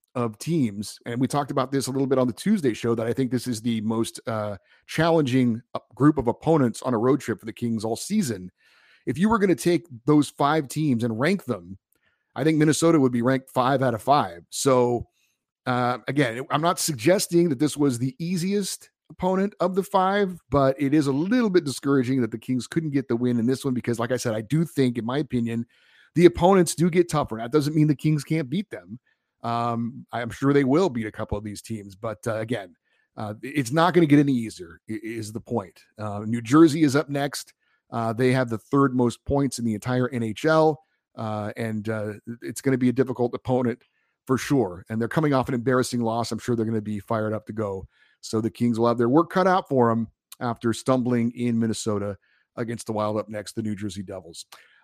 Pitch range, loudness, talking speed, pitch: 115-150 Hz, -24 LUFS, 225 wpm, 125 Hz